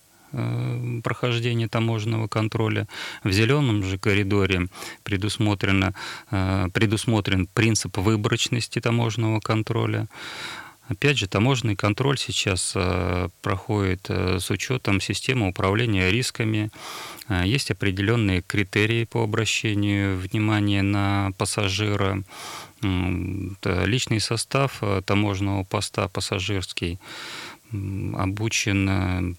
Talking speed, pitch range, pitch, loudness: 80 wpm, 95-115 Hz, 105 Hz, -24 LUFS